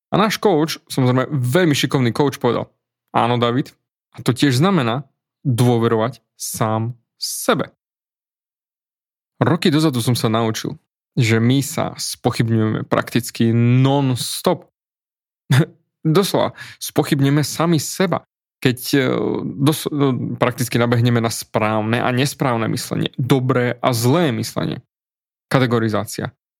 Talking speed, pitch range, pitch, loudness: 105 wpm, 120-150 Hz, 130 Hz, -19 LUFS